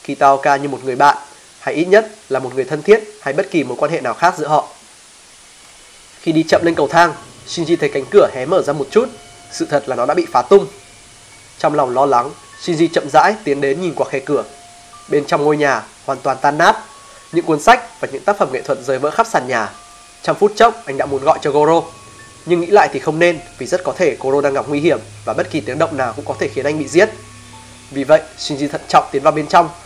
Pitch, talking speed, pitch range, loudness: 150 Hz, 255 wpm, 135-175 Hz, -15 LUFS